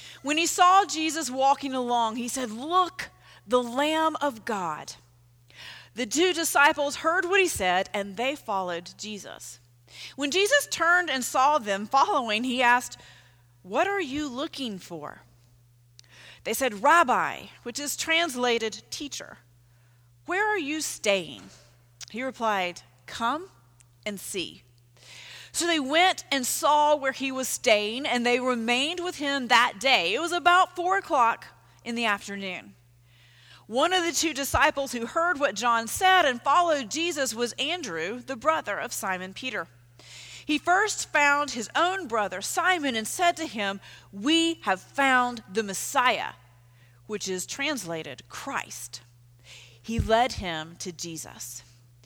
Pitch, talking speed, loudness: 245 Hz, 140 wpm, -25 LUFS